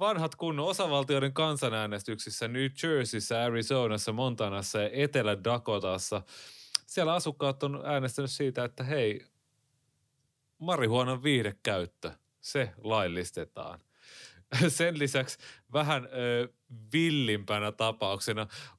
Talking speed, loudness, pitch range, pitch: 85 wpm, -31 LUFS, 110-145 Hz, 130 Hz